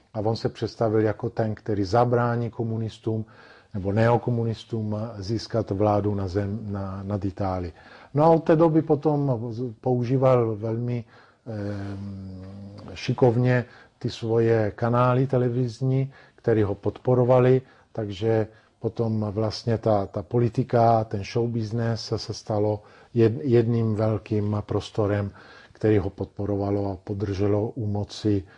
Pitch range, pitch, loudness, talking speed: 105-120 Hz, 110 Hz, -25 LUFS, 120 wpm